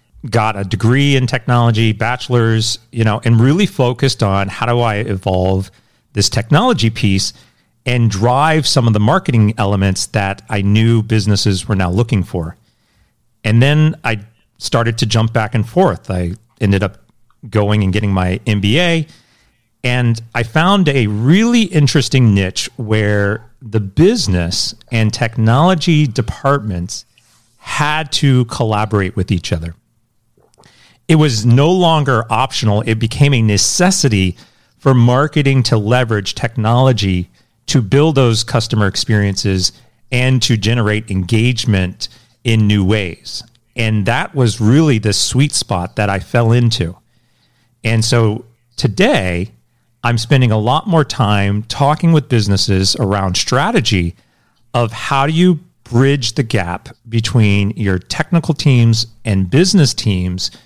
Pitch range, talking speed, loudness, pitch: 105-130 Hz, 135 wpm, -14 LUFS, 115 Hz